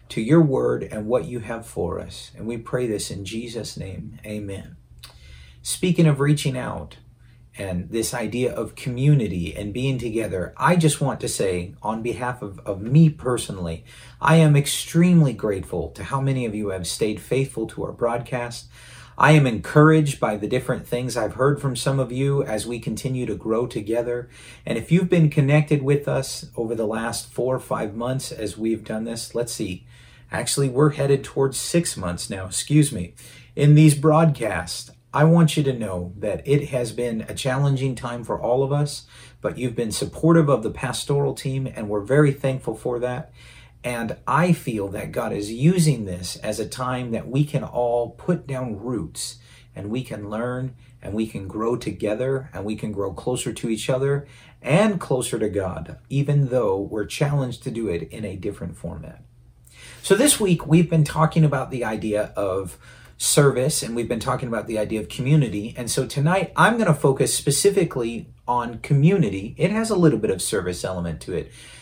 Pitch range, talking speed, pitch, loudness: 110-145 Hz, 190 wpm, 125 Hz, -22 LUFS